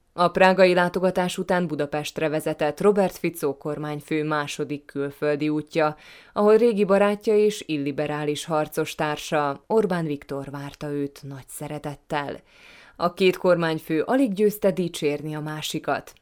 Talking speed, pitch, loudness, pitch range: 120 wpm, 155 Hz, -23 LUFS, 150-185 Hz